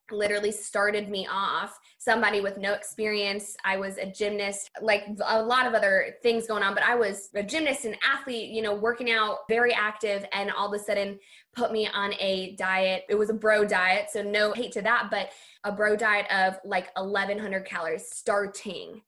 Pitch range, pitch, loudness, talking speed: 200-220 Hz, 205 Hz, -26 LUFS, 195 wpm